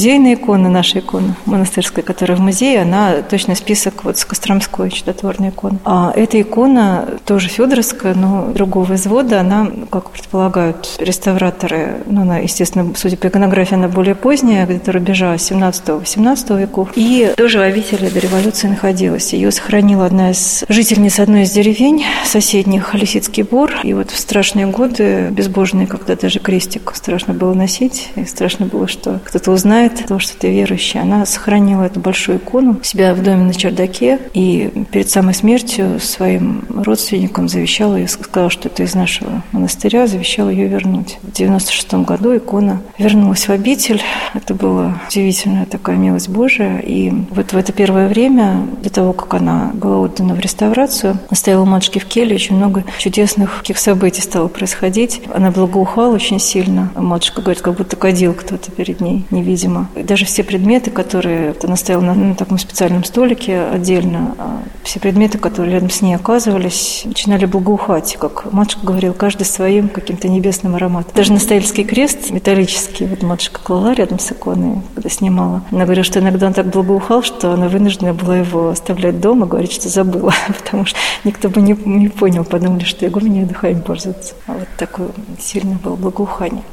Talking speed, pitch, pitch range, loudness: 165 wpm, 195 Hz, 185-210 Hz, -13 LUFS